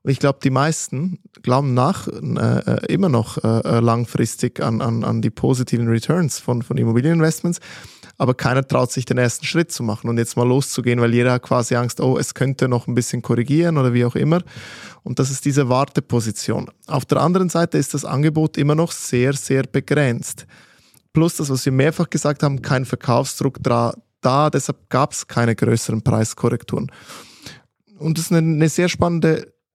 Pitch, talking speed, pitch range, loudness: 135 Hz, 180 wpm, 120-155 Hz, -19 LUFS